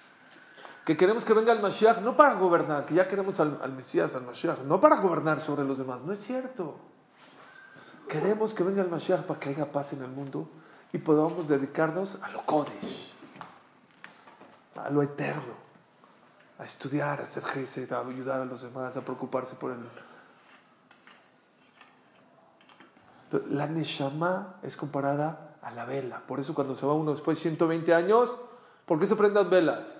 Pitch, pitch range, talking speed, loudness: 155 Hz, 135-185 Hz, 170 wpm, -28 LUFS